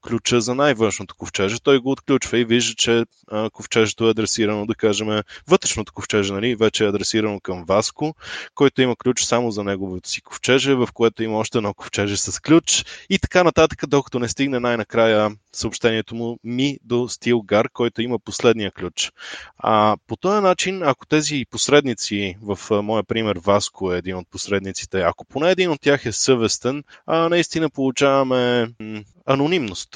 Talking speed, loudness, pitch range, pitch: 160 wpm, -20 LUFS, 105-135 Hz, 115 Hz